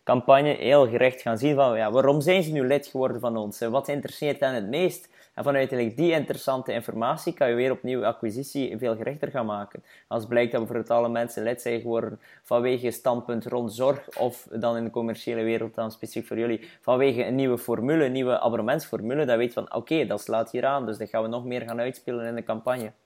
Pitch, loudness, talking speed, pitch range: 120 Hz, -26 LUFS, 230 wpm, 115-135 Hz